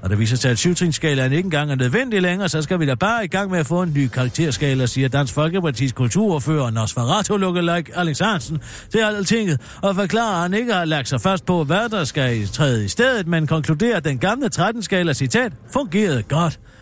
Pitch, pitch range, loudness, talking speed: 165 Hz, 135-195 Hz, -19 LUFS, 210 wpm